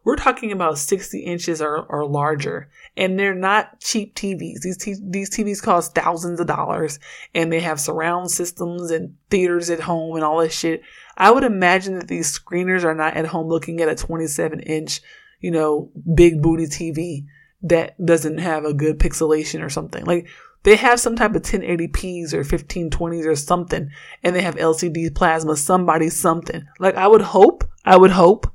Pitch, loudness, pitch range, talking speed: 170 Hz, -19 LUFS, 160-185 Hz, 185 wpm